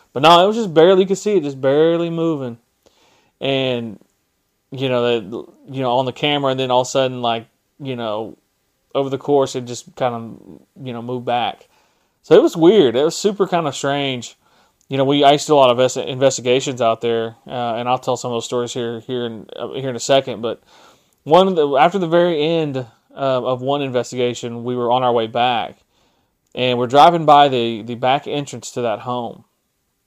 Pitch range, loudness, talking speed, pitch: 120-145 Hz, -17 LUFS, 220 wpm, 130 Hz